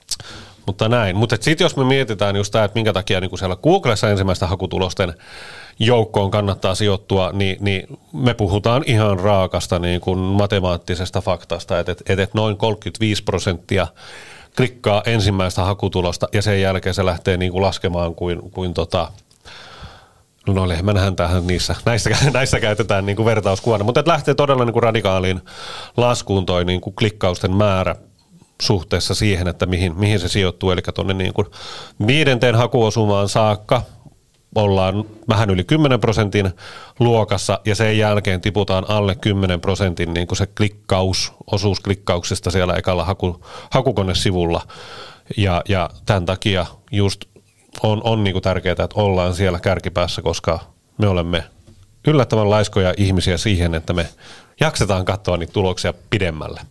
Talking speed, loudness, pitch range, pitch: 140 wpm, -18 LUFS, 95-110 Hz, 100 Hz